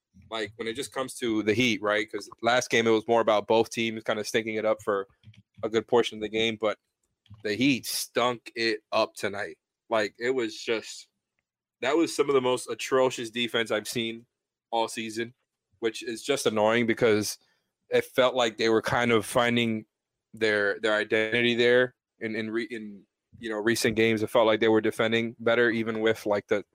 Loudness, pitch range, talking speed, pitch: -26 LUFS, 110-120 Hz, 200 wpm, 115 Hz